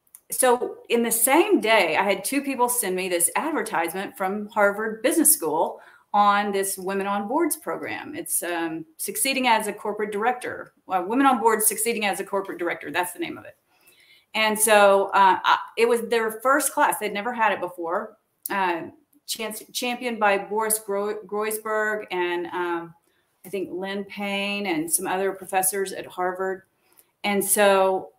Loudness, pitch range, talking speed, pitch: -23 LUFS, 195-245 Hz, 170 wpm, 210 Hz